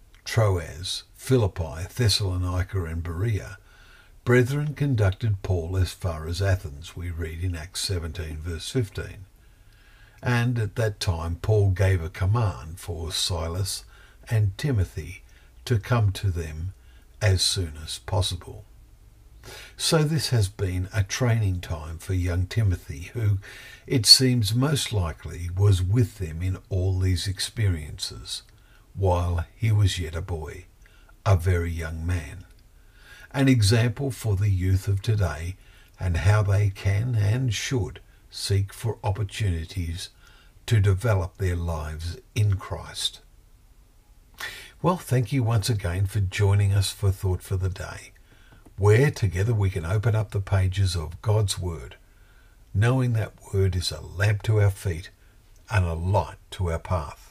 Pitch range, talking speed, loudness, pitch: 90-105 Hz, 140 wpm, -25 LUFS, 95 Hz